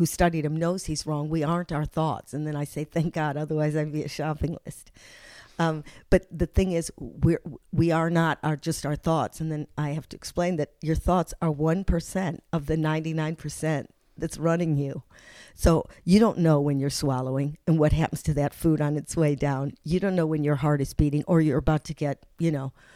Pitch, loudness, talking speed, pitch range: 155 Hz, -26 LUFS, 225 wpm, 150-165 Hz